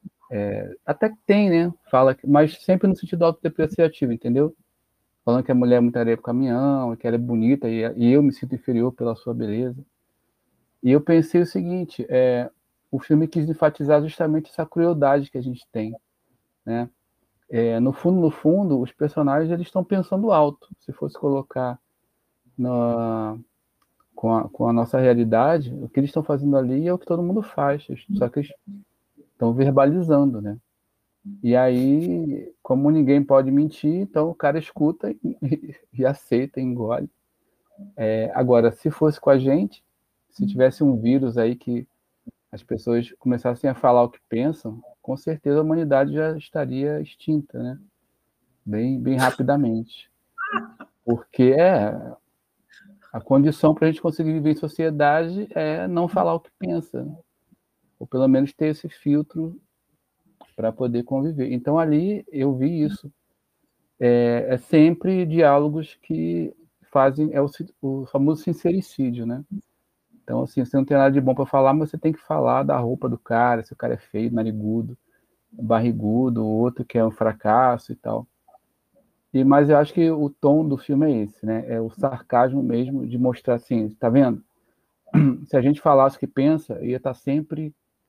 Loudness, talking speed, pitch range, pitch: -21 LUFS, 165 wpm, 120-155 Hz, 135 Hz